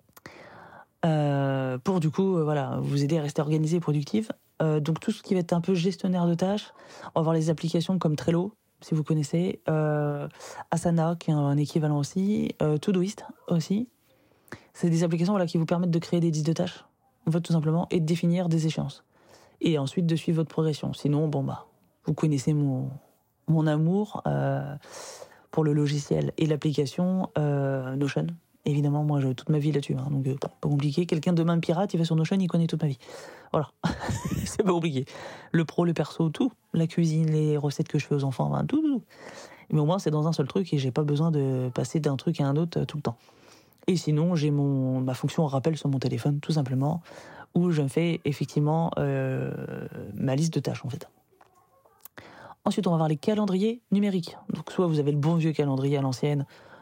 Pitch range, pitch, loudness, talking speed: 145-175 Hz, 160 Hz, -27 LUFS, 210 wpm